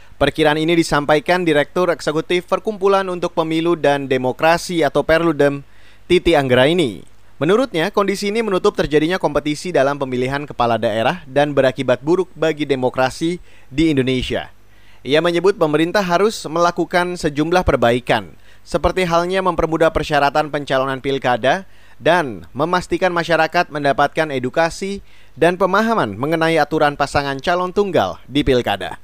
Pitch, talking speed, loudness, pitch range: 155 Hz, 120 wpm, -17 LUFS, 135-175 Hz